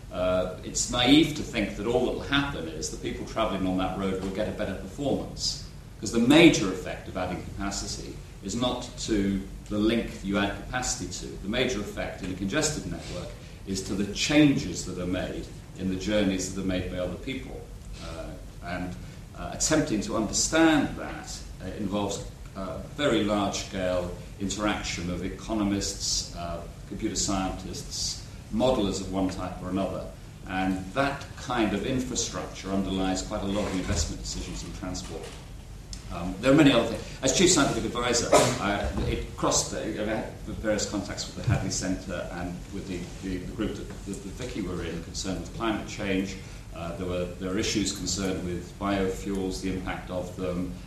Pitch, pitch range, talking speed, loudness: 95 Hz, 90-105 Hz, 175 wpm, -28 LUFS